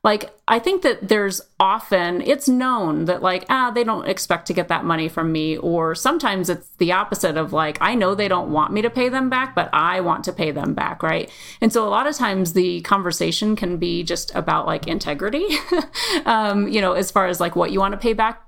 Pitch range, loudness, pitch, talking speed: 175-235 Hz, -20 LUFS, 195 Hz, 235 wpm